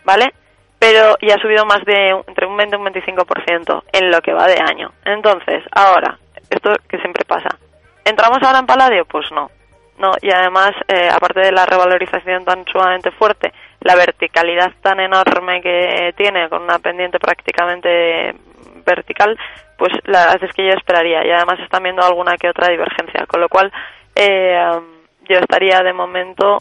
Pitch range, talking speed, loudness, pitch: 175-195 Hz, 170 wpm, -13 LUFS, 185 Hz